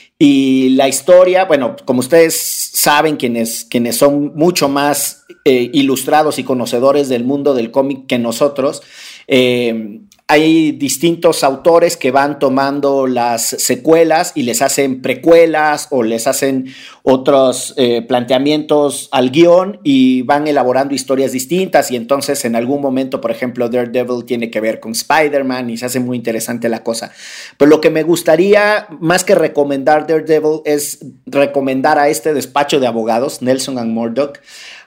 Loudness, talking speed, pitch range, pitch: -13 LUFS, 150 wpm, 125-155 Hz, 140 Hz